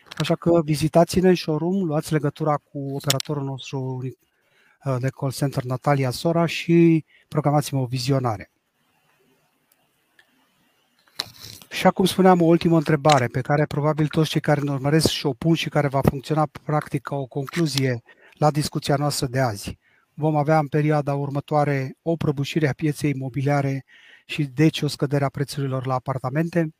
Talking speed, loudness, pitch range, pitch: 150 wpm, -22 LUFS, 135-155 Hz, 150 Hz